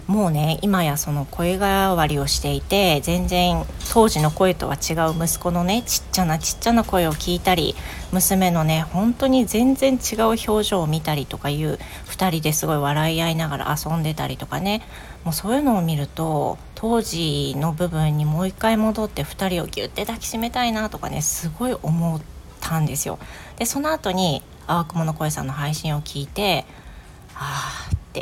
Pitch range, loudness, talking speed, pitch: 155-205 Hz, -21 LUFS, 335 characters per minute, 170 Hz